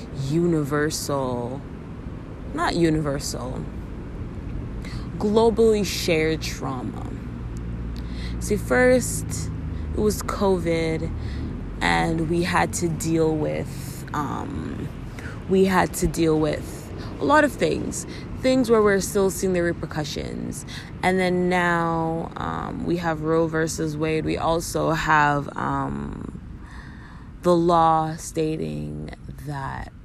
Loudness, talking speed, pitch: -23 LUFS, 100 wpm, 160 Hz